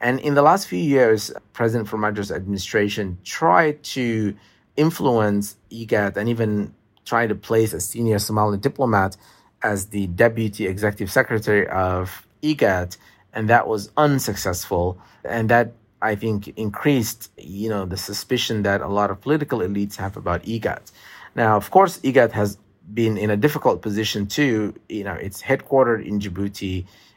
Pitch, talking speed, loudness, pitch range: 105 Hz, 150 wpm, -21 LUFS, 100-115 Hz